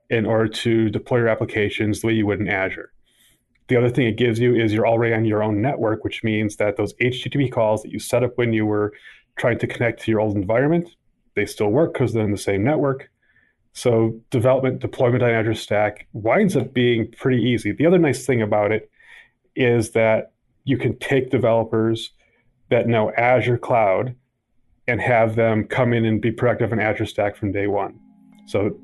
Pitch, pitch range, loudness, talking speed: 115 Hz, 110-125 Hz, -20 LUFS, 200 wpm